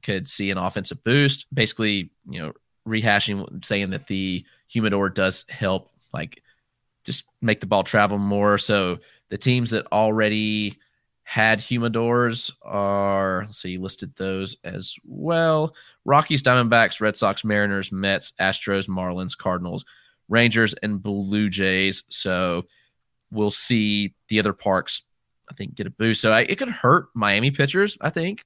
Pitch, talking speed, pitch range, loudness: 105 Hz, 145 wpm, 100-120 Hz, -21 LUFS